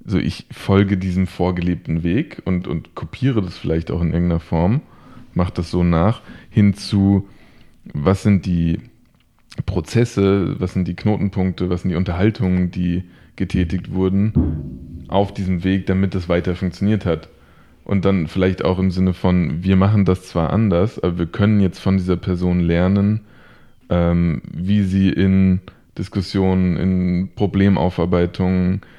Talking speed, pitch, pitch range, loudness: 145 wpm, 95 Hz, 85-100 Hz, -19 LUFS